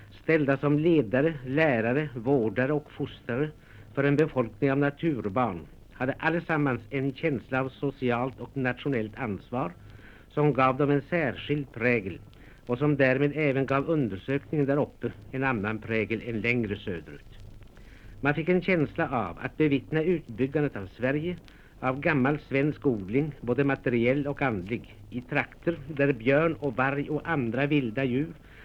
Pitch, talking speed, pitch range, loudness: 135 Hz, 145 wpm, 120-145 Hz, -28 LUFS